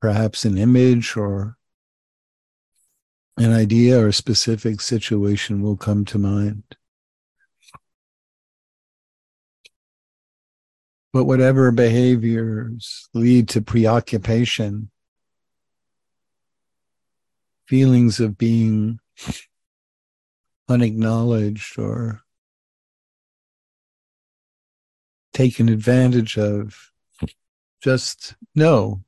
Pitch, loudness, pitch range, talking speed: 115 Hz, -18 LUFS, 105-120 Hz, 60 wpm